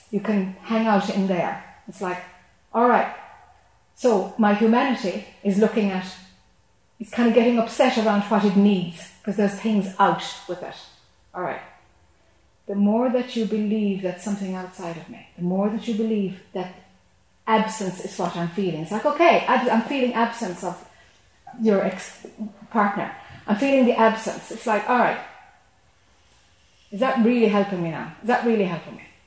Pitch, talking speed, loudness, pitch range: 205 Hz, 170 wpm, -22 LUFS, 185-225 Hz